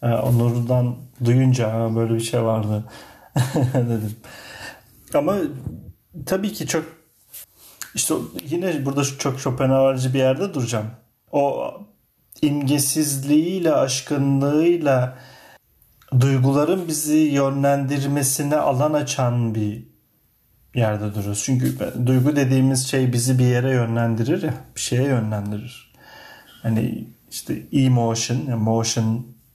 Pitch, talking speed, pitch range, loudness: 130 Hz, 95 wpm, 115-145 Hz, -21 LUFS